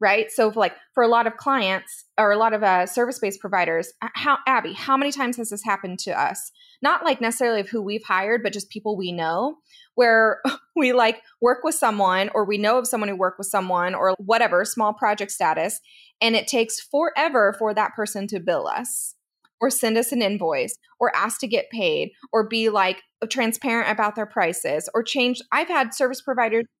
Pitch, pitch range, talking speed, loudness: 225 Hz, 200-255 Hz, 200 wpm, -22 LUFS